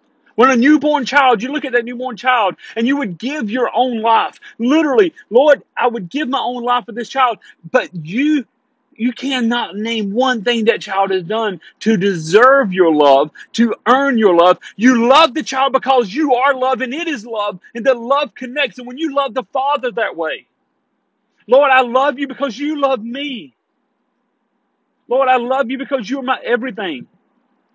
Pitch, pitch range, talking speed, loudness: 255 Hz, 230-275 Hz, 190 wpm, -15 LUFS